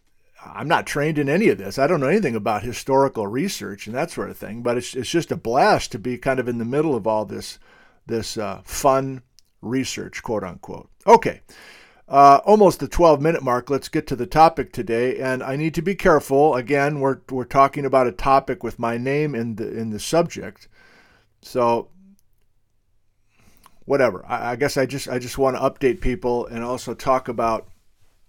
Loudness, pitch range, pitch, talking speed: -20 LUFS, 115-140 Hz, 130 Hz, 195 wpm